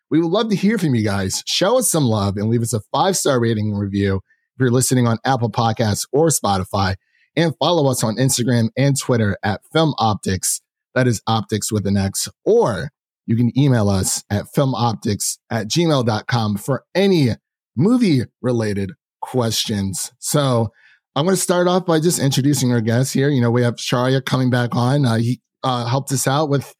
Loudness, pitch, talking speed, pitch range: -18 LUFS, 125 Hz, 190 wpm, 110-140 Hz